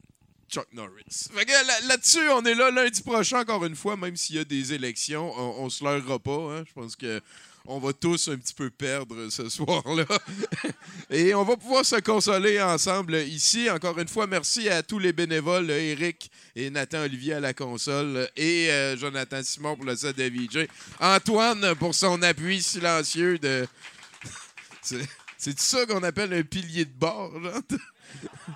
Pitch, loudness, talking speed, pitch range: 165 Hz, -25 LUFS, 175 wpm, 140-195 Hz